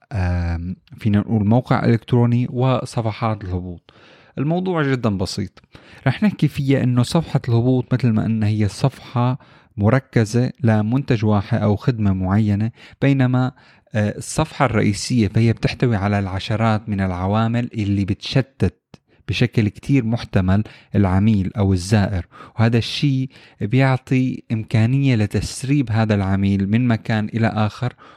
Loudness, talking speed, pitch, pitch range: -19 LUFS, 115 wpm, 115 Hz, 105-130 Hz